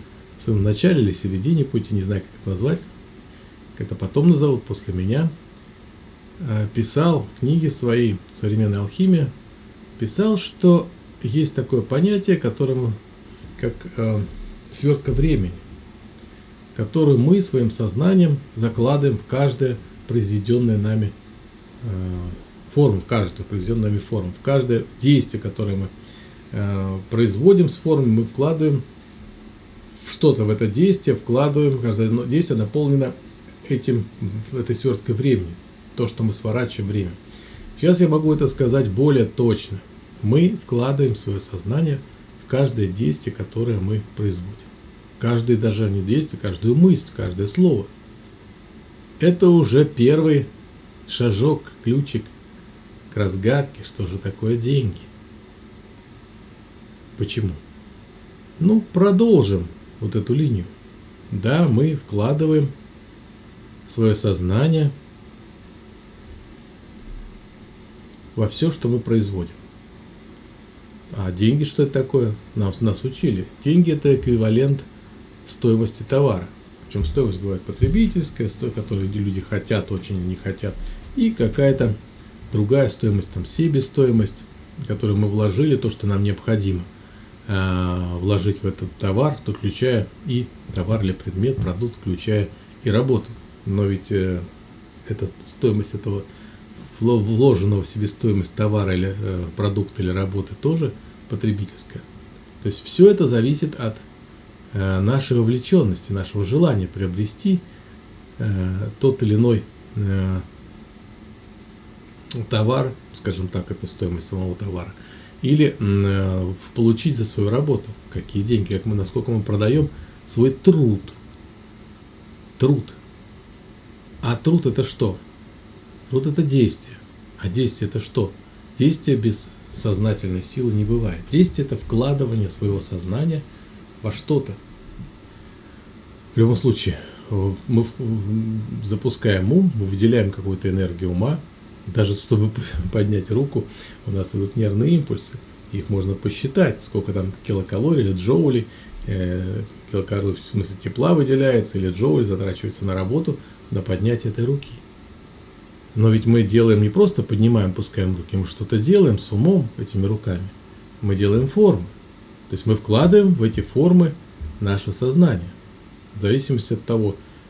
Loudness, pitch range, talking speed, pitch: -20 LUFS, 100-130 Hz, 120 wpm, 110 Hz